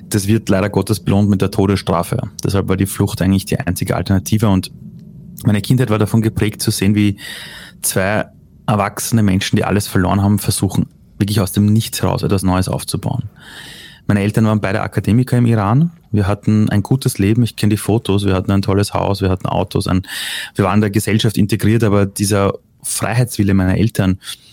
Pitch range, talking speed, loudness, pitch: 100-110 Hz, 190 wpm, -16 LUFS, 105 Hz